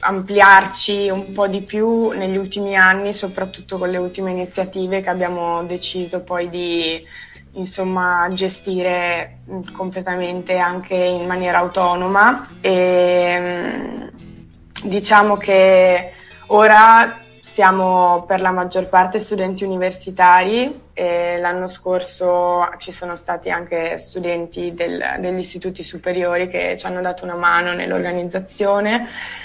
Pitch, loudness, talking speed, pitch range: 185 Hz, -17 LUFS, 110 wpm, 180-190 Hz